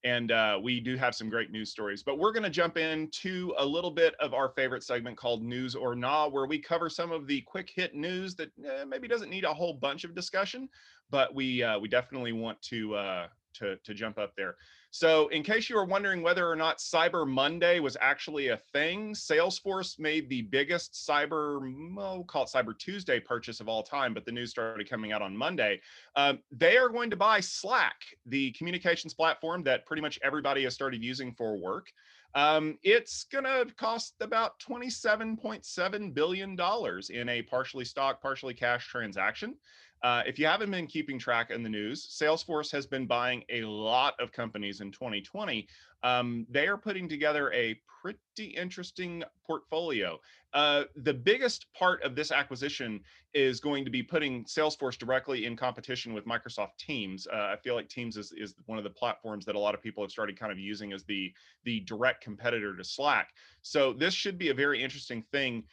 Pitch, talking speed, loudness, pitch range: 140 Hz, 195 wpm, -31 LUFS, 120-175 Hz